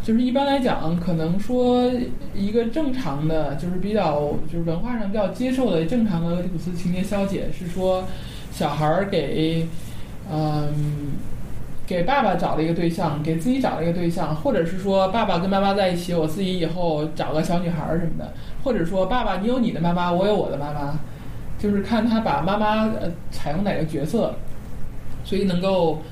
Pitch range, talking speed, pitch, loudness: 160-205 Hz, 285 characters per minute, 175 Hz, -23 LUFS